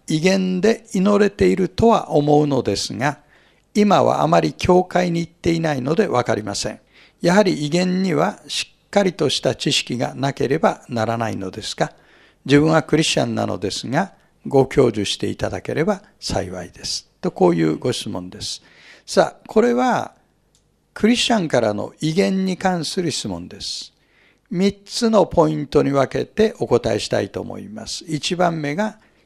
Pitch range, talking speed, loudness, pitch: 125-195 Hz, 320 characters per minute, -19 LUFS, 160 Hz